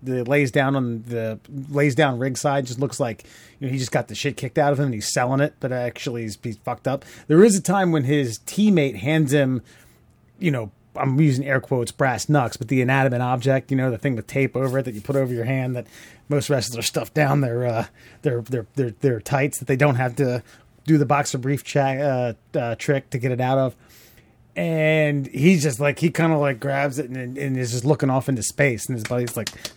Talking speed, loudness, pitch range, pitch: 245 wpm, -22 LUFS, 120-145 Hz, 135 Hz